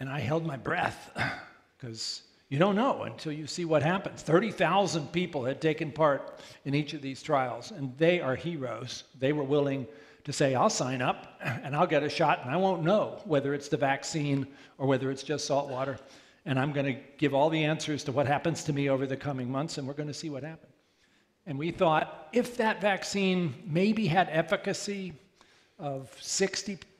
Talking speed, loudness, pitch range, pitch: 200 wpm, -30 LUFS, 135-170 Hz, 150 Hz